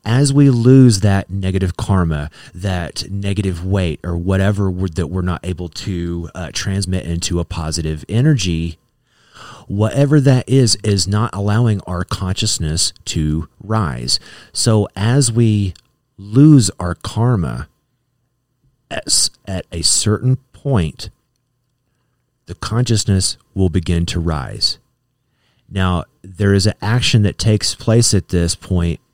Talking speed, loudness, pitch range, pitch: 125 wpm, -16 LUFS, 90-120 Hz, 100 Hz